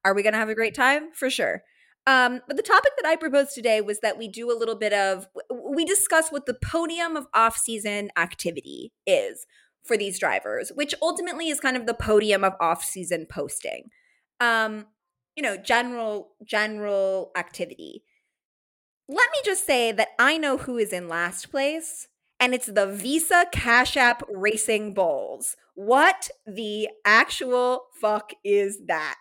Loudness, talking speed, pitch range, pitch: -23 LUFS, 165 wpm, 210-290 Hz, 235 Hz